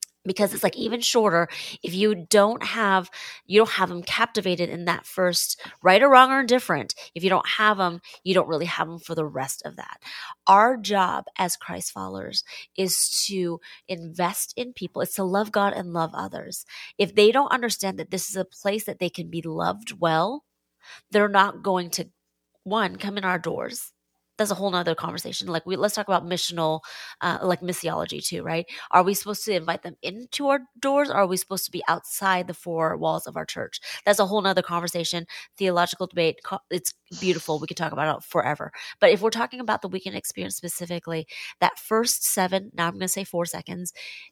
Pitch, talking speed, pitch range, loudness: 185 Hz, 205 wpm, 170-205 Hz, -24 LUFS